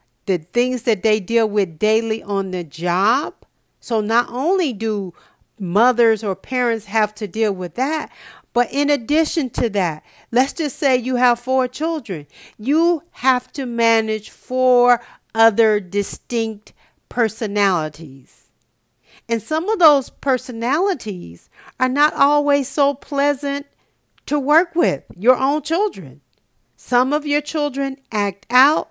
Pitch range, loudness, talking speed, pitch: 210-280 Hz, -19 LUFS, 135 wpm, 245 Hz